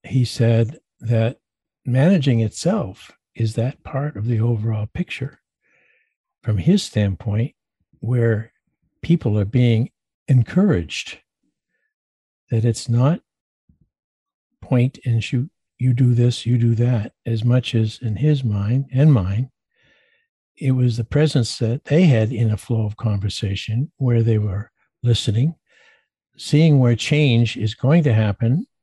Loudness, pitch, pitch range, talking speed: -20 LUFS, 120 Hz, 115-140 Hz, 130 wpm